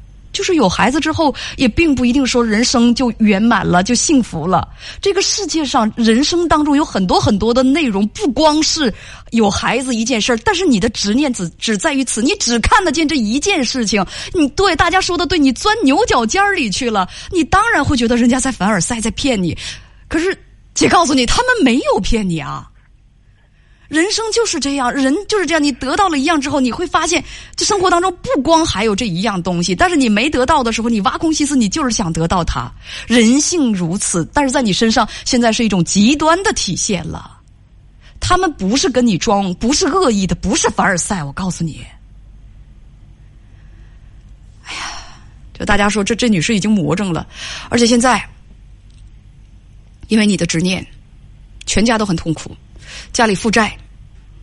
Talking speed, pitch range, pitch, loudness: 275 characters per minute, 200-310 Hz, 240 Hz, -14 LUFS